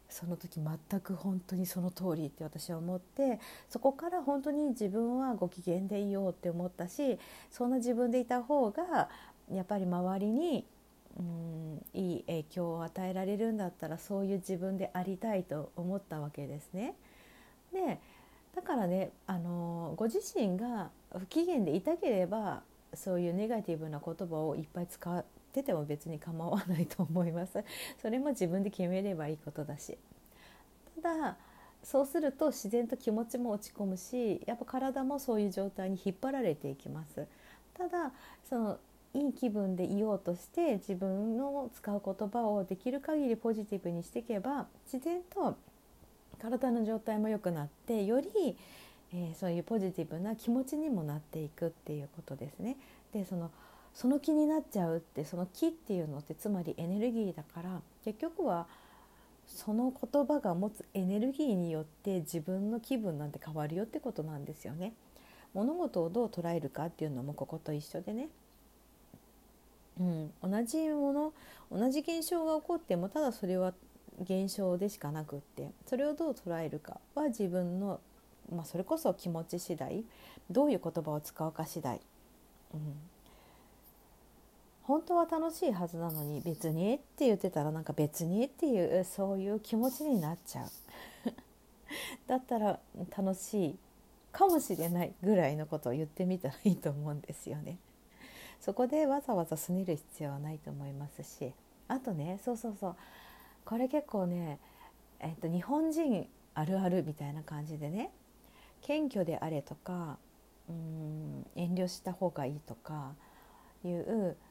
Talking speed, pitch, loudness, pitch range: 320 characters per minute, 190 Hz, -36 LUFS, 170-245 Hz